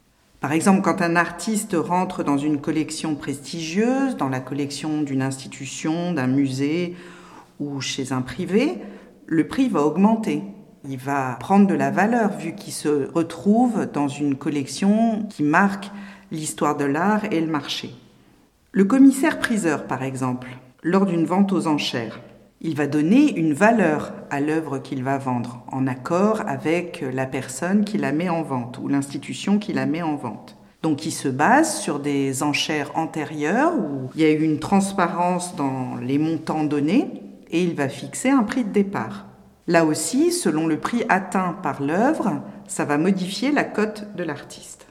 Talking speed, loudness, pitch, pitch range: 165 wpm, -22 LUFS, 160 Hz, 145-195 Hz